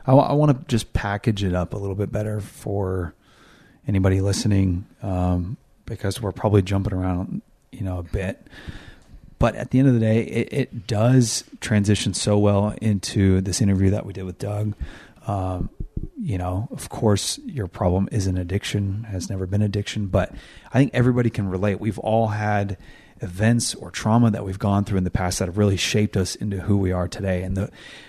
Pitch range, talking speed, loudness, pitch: 95-110 Hz, 195 wpm, -23 LUFS, 100 Hz